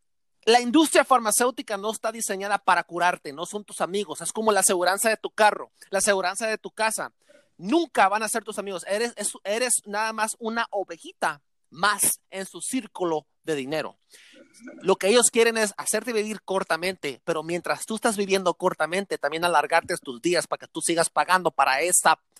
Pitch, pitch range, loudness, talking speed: 200 Hz, 170-220 Hz, -24 LUFS, 180 wpm